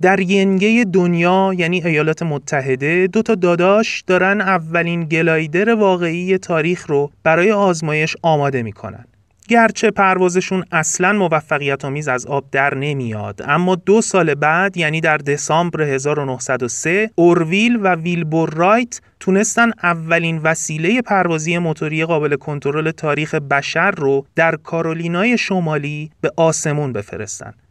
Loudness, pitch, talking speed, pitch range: -16 LUFS, 165 Hz, 120 wpm, 150-185 Hz